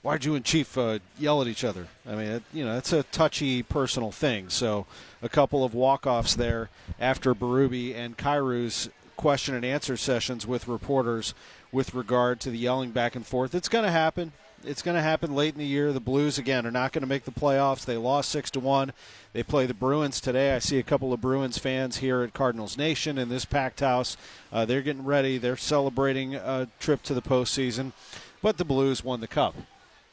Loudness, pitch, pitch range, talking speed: -27 LUFS, 130 Hz, 125-140 Hz, 210 wpm